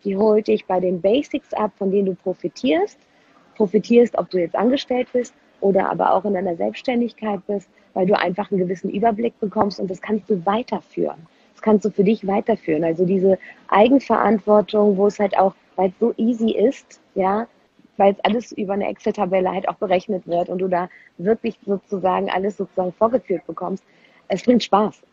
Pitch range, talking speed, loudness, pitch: 190-220 Hz, 185 wpm, -20 LUFS, 205 Hz